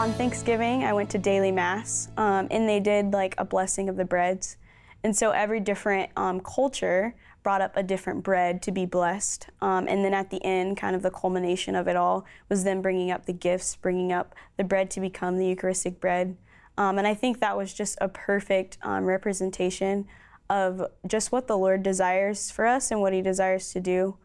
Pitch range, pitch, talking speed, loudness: 185-205 Hz, 190 Hz, 210 wpm, -26 LUFS